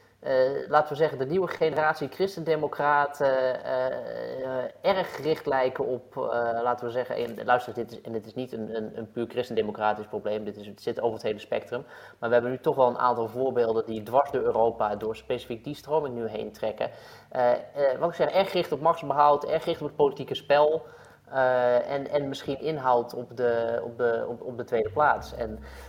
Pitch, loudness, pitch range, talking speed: 130 Hz, -27 LUFS, 120-150 Hz, 215 wpm